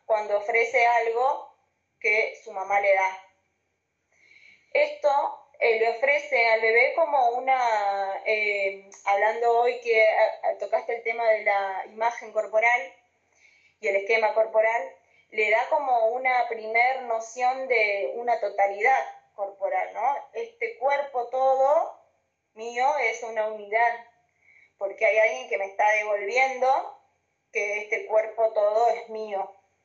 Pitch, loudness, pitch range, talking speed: 230 Hz, -24 LUFS, 210-260 Hz, 125 wpm